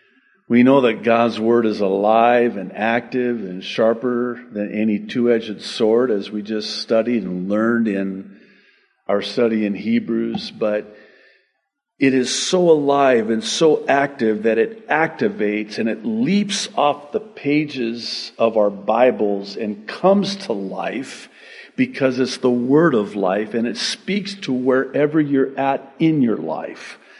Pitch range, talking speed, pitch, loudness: 105-140 Hz, 150 wpm, 120 Hz, -19 LUFS